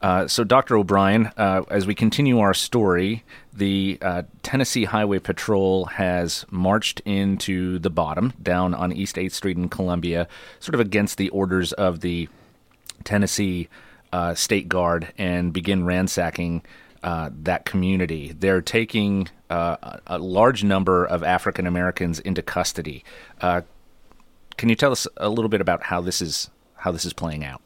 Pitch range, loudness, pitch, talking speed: 90-100 Hz, -22 LUFS, 95 Hz, 155 wpm